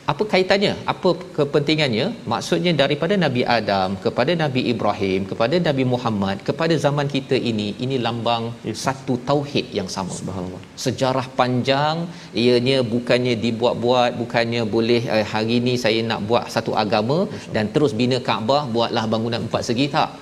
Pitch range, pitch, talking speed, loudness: 115-145 Hz, 125 Hz, 140 wpm, -20 LUFS